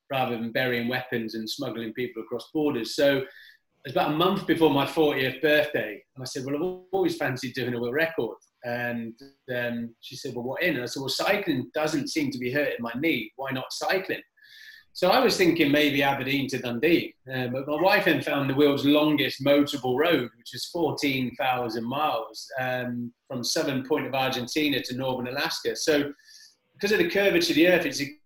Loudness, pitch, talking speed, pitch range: -26 LUFS, 140 Hz, 200 wpm, 125-155 Hz